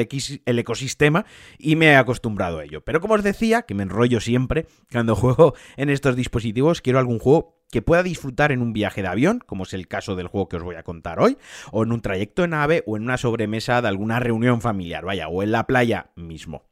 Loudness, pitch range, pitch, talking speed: -21 LUFS, 100-140 Hz, 120 Hz, 230 wpm